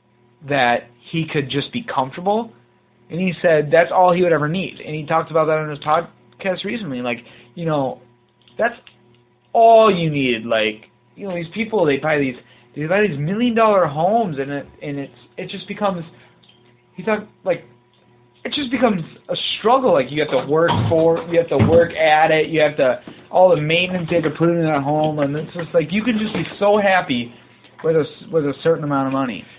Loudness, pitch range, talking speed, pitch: -18 LUFS, 130-185 Hz, 210 wpm, 160 Hz